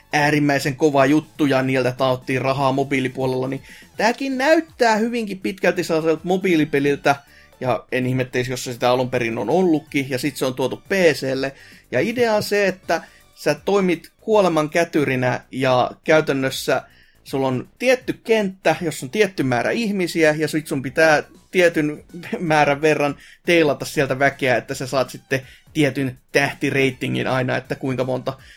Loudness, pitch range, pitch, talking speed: -20 LUFS, 130-170 Hz, 145 Hz, 150 wpm